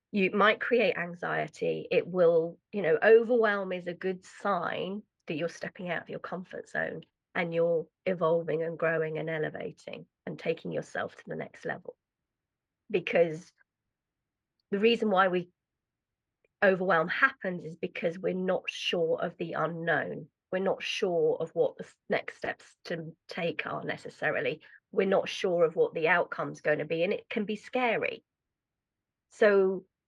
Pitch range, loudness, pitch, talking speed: 170-245 Hz, -30 LUFS, 190 Hz, 155 wpm